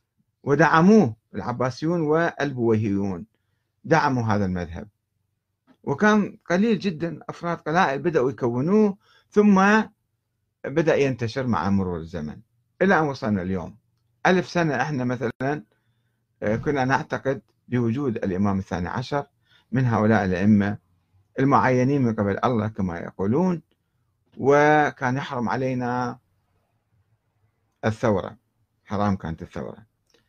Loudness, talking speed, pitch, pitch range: -23 LUFS, 95 wpm, 115 Hz, 105-140 Hz